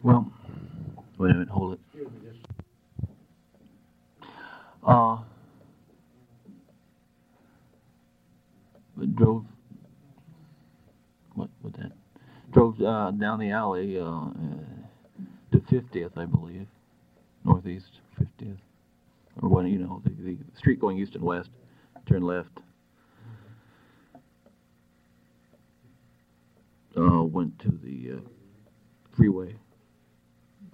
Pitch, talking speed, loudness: 90 Hz, 85 wpm, -26 LUFS